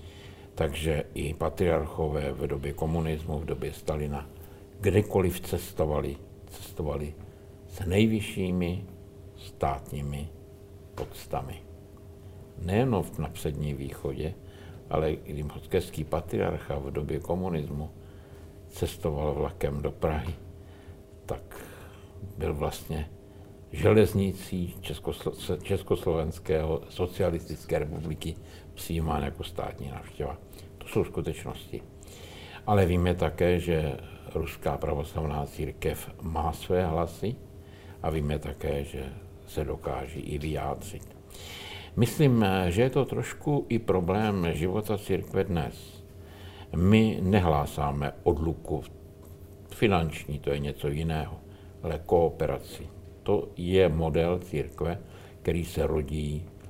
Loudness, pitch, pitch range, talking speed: -30 LUFS, 85 Hz, 80-100 Hz, 95 wpm